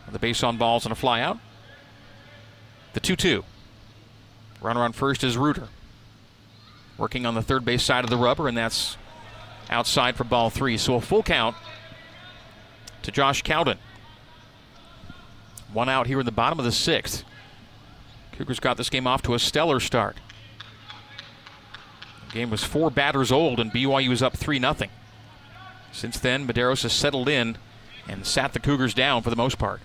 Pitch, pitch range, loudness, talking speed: 115 Hz, 110-130 Hz, -24 LUFS, 165 wpm